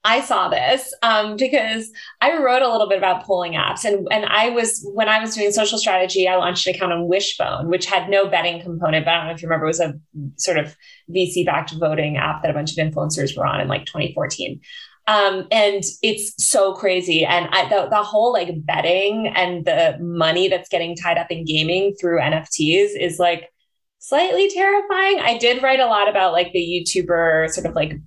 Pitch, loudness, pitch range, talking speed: 185 Hz, -18 LUFS, 170-215 Hz, 210 wpm